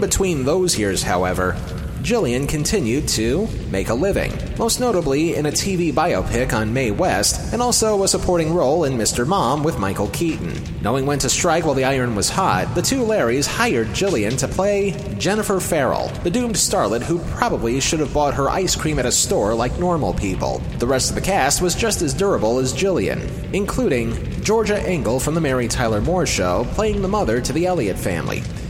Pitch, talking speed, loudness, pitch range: 150 Hz, 190 wpm, -19 LUFS, 125-190 Hz